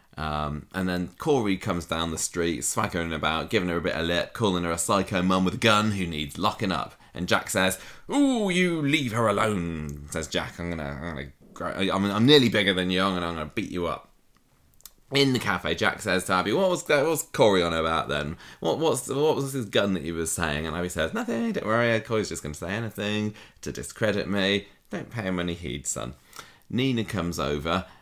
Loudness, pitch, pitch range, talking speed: -26 LUFS, 95 Hz, 85-110 Hz, 220 wpm